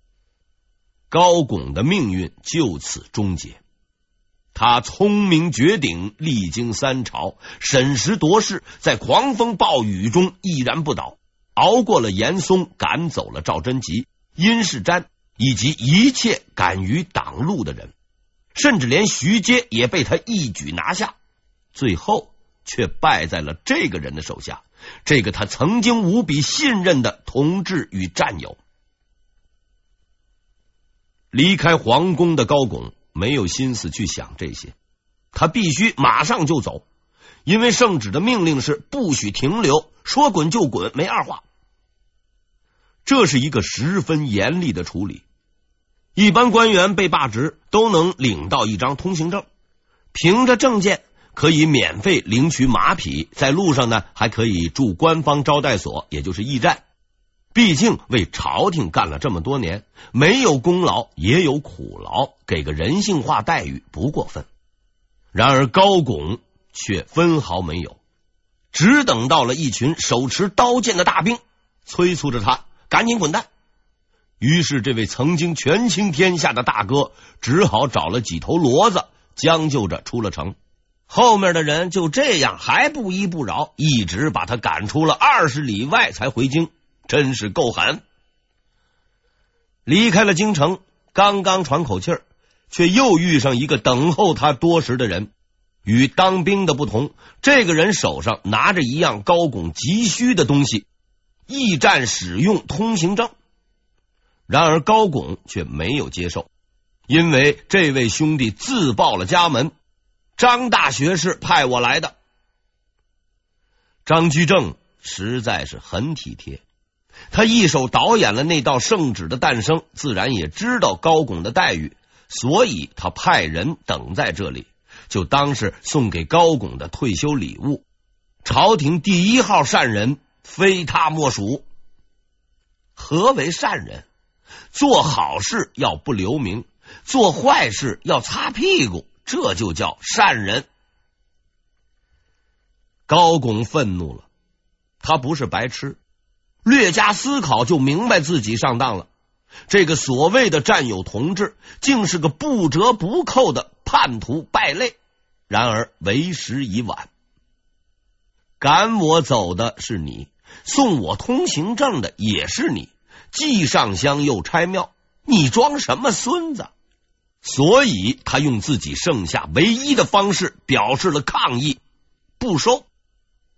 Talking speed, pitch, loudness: 200 characters per minute, 145 Hz, -18 LUFS